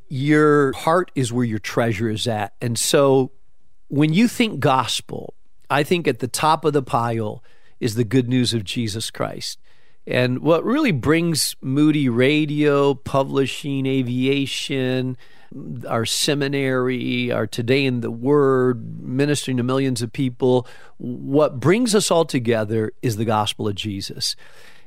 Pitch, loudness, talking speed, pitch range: 130 Hz, -20 LUFS, 140 wpm, 120-145 Hz